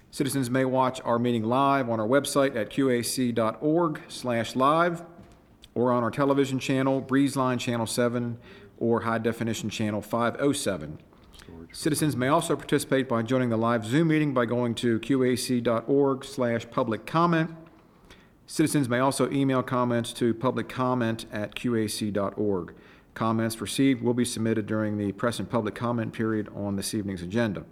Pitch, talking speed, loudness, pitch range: 120 Hz, 145 wpm, -26 LUFS, 115-135 Hz